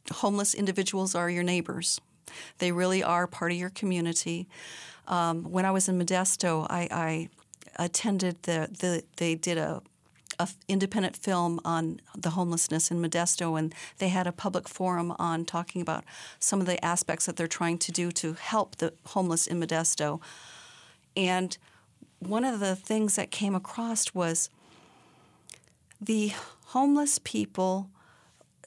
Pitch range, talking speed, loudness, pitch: 170-190 Hz, 145 wpm, -29 LUFS, 175 Hz